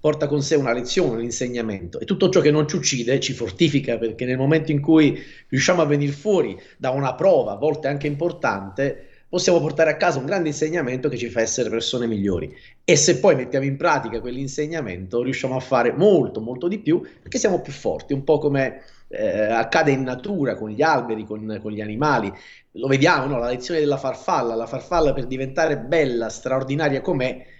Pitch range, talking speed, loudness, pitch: 120-155 Hz, 200 wpm, -21 LUFS, 135 Hz